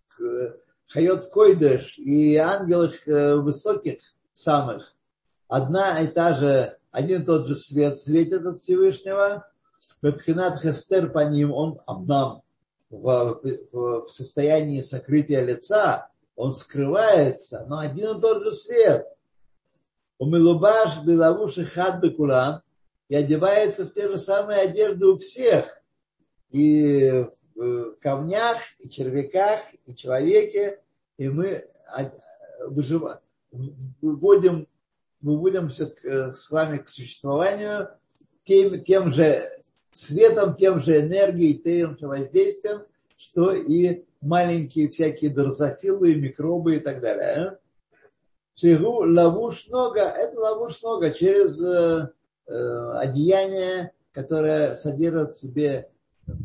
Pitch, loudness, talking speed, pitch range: 165 Hz, -22 LUFS, 100 wpm, 145-195 Hz